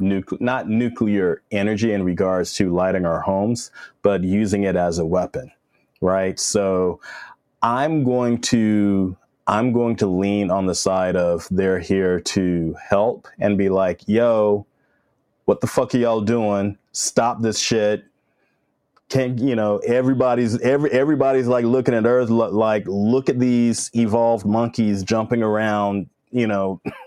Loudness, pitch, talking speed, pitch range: -20 LUFS, 105 Hz, 145 wpm, 95-120 Hz